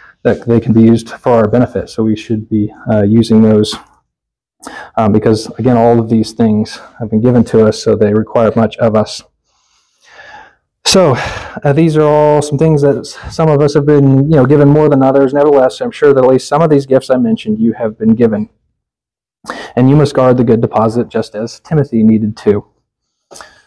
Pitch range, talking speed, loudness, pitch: 110-145 Hz, 205 wpm, -11 LUFS, 120 Hz